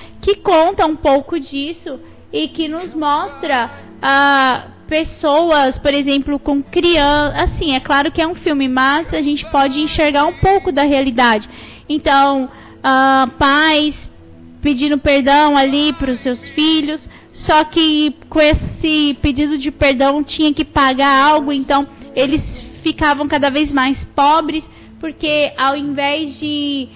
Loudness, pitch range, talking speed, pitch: -14 LUFS, 275-310 Hz, 140 wpm, 290 Hz